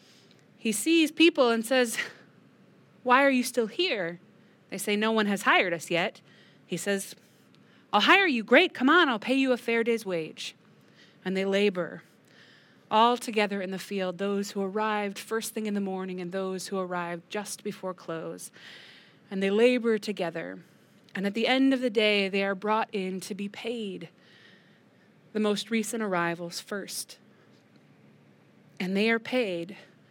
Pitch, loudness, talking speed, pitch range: 205 Hz, -27 LUFS, 165 wpm, 185-230 Hz